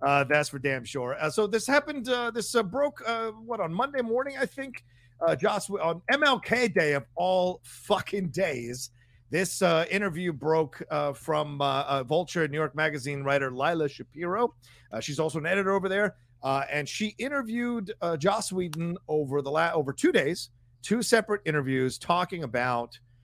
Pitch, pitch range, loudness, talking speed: 165 Hz, 140-210 Hz, -28 LUFS, 180 wpm